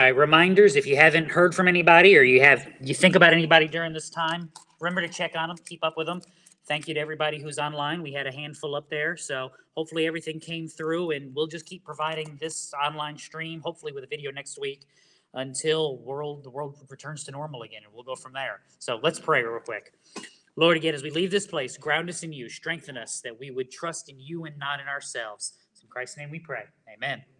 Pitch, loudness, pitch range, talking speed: 155 Hz, -23 LUFS, 145-165 Hz, 230 wpm